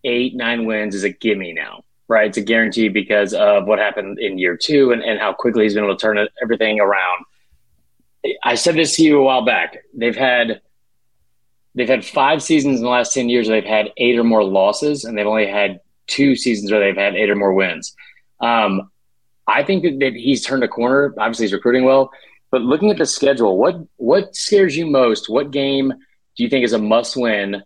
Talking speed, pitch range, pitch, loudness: 215 wpm, 105-135 Hz, 120 Hz, -16 LUFS